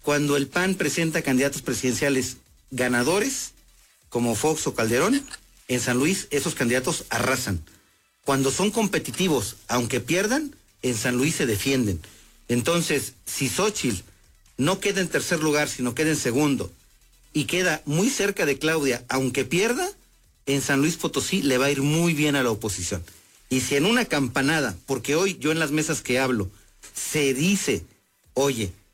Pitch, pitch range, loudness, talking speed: 140 Hz, 125-160 Hz, -24 LUFS, 160 wpm